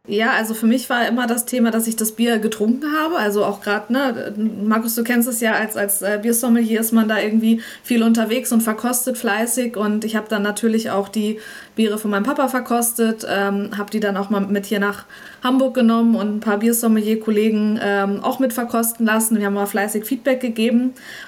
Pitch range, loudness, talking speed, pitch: 210-240 Hz, -19 LUFS, 205 wpm, 225 Hz